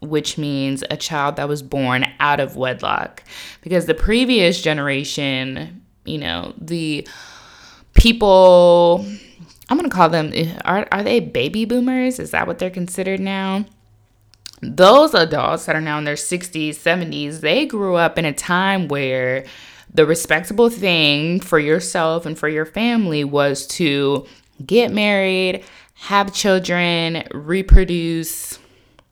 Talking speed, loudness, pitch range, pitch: 135 wpm, -17 LUFS, 145-190 Hz, 165 Hz